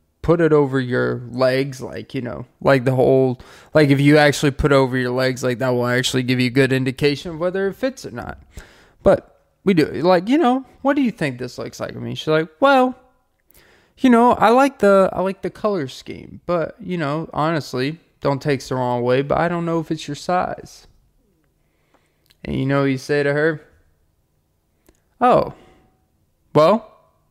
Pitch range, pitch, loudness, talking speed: 130-180 Hz, 145 Hz, -18 LUFS, 200 wpm